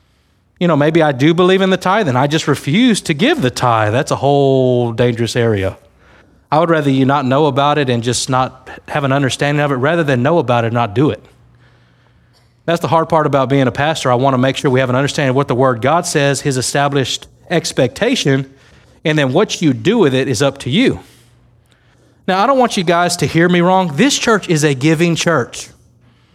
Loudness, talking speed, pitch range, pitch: -14 LUFS, 230 wpm, 125-165 Hz, 140 Hz